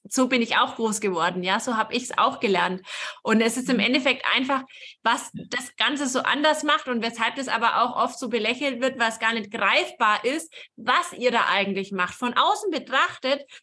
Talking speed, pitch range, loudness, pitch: 210 wpm, 225-270 Hz, -23 LUFS, 245 Hz